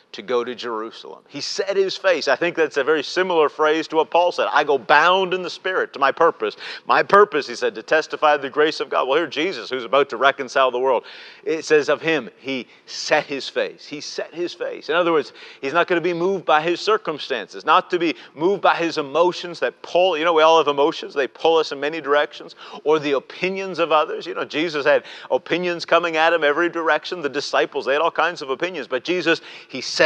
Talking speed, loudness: 240 wpm, -20 LUFS